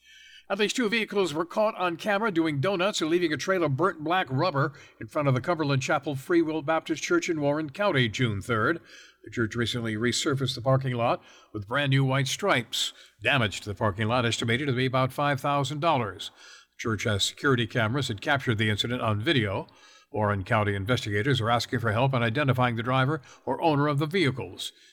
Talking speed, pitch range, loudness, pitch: 195 wpm, 115-160 Hz, -26 LUFS, 135 Hz